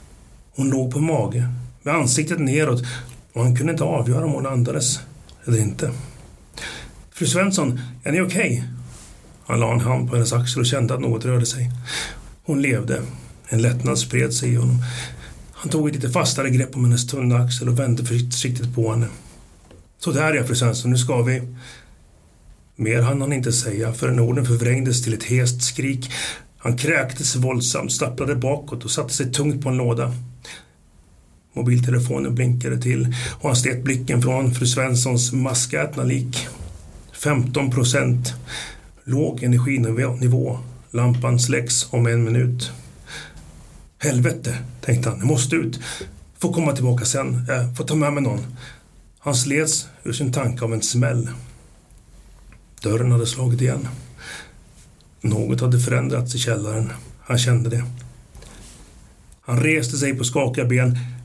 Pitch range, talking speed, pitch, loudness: 120-135 Hz, 150 wpm, 125 Hz, -21 LUFS